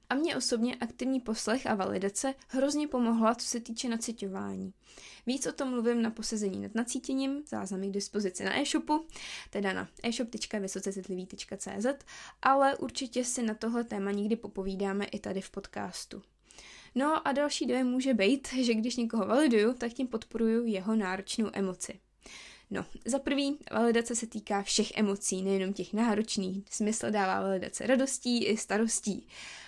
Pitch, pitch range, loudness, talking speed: 230 Hz, 200-255 Hz, -32 LUFS, 150 wpm